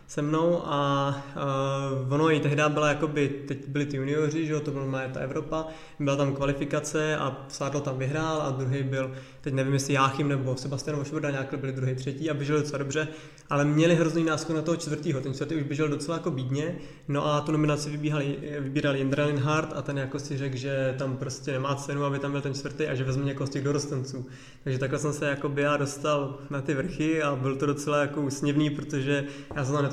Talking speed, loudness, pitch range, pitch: 220 wpm, -28 LUFS, 140-150 Hz, 145 Hz